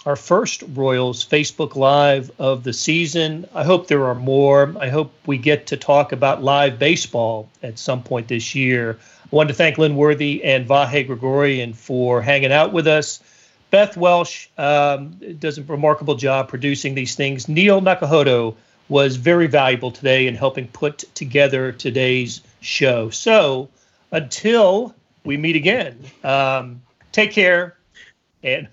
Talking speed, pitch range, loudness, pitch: 150 wpm, 130-155 Hz, -17 LUFS, 140 Hz